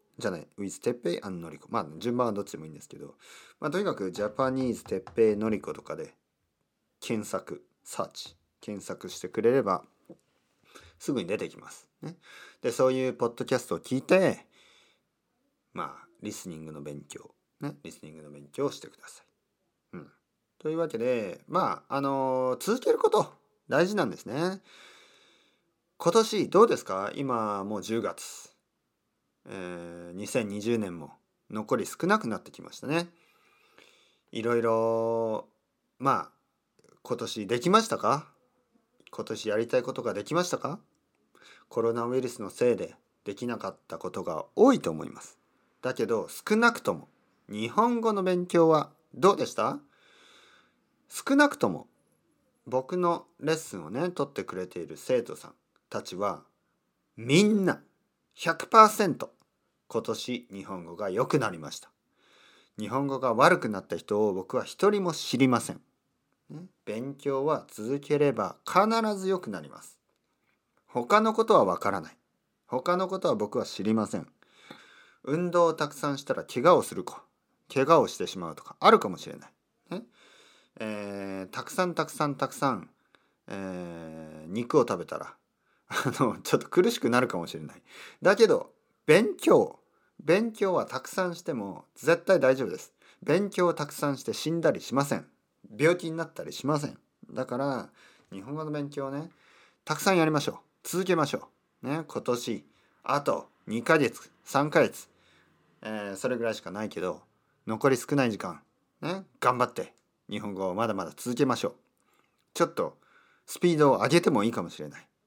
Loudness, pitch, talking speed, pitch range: -28 LUFS, 135 Hz, 295 characters per minute, 110-180 Hz